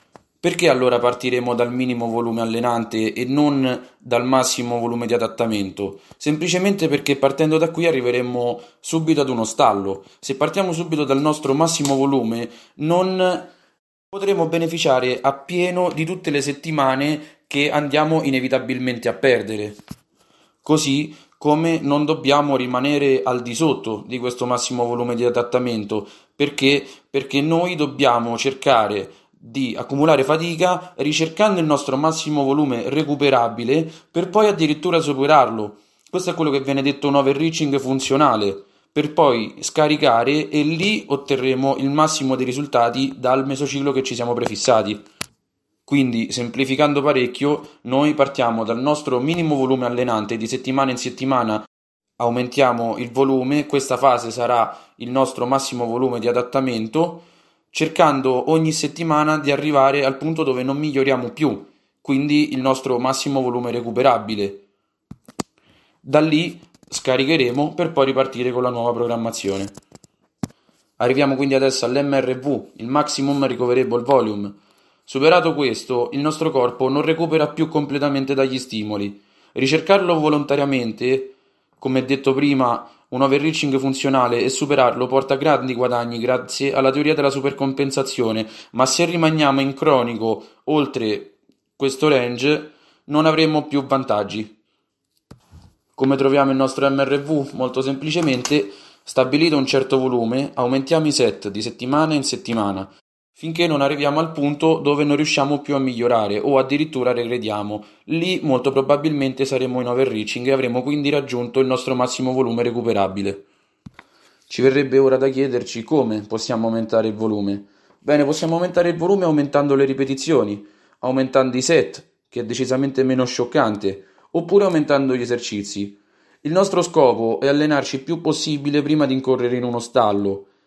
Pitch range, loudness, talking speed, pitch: 120-150 Hz, -19 LUFS, 135 wpm, 135 Hz